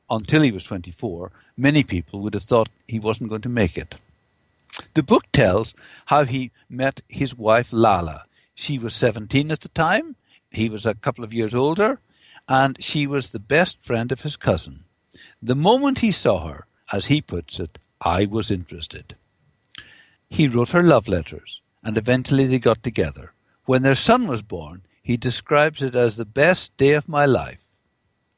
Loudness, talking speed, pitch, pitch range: -21 LUFS, 175 wpm, 120 Hz, 105-140 Hz